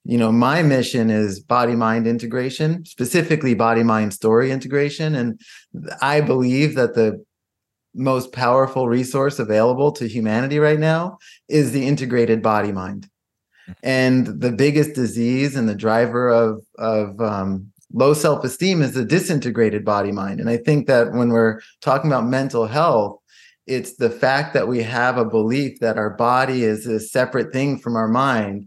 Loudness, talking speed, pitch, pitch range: -19 LUFS, 160 wpm, 120 Hz, 110-135 Hz